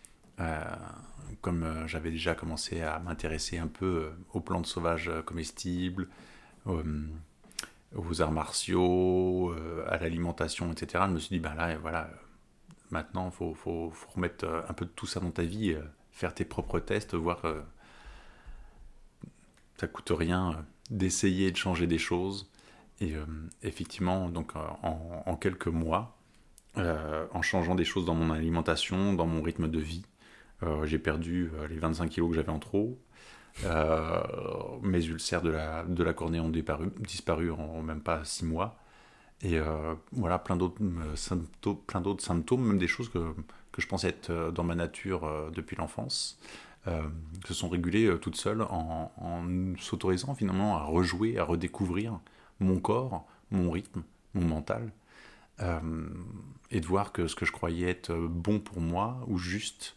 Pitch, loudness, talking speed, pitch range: 85 Hz, -33 LUFS, 175 wpm, 80-95 Hz